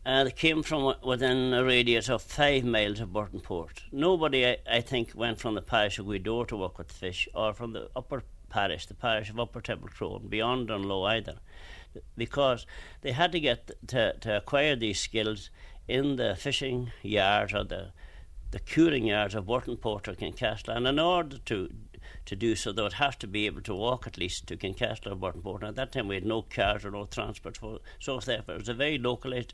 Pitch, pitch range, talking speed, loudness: 115 Hz, 100-125 Hz, 210 wpm, -30 LUFS